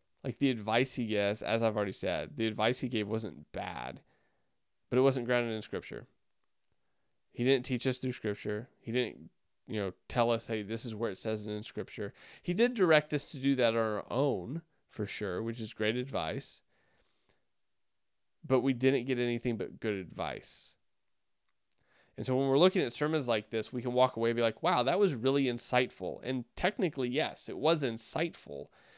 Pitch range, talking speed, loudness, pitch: 110-135 Hz, 195 wpm, -32 LUFS, 120 Hz